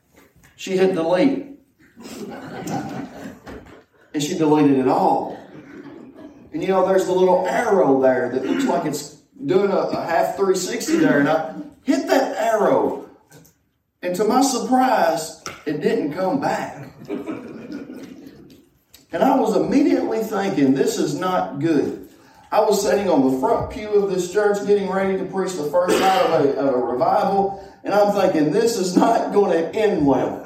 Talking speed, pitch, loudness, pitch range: 155 wpm, 195 Hz, -19 LUFS, 180-260 Hz